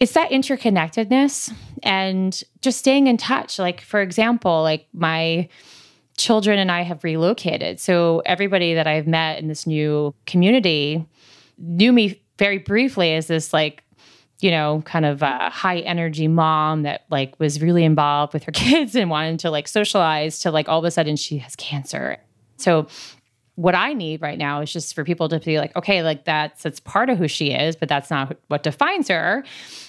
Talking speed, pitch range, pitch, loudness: 185 wpm, 155-190 Hz, 165 Hz, -20 LUFS